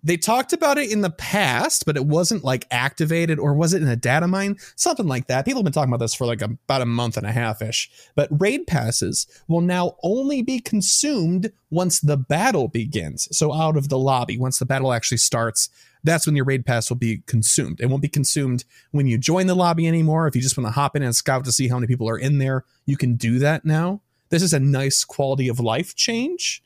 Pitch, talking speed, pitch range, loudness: 145 Hz, 245 wpm, 125-170 Hz, -21 LUFS